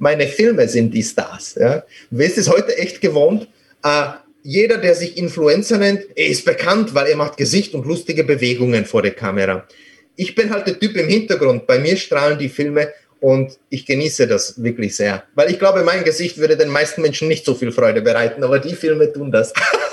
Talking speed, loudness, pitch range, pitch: 210 wpm, -16 LUFS, 140-195 Hz, 155 Hz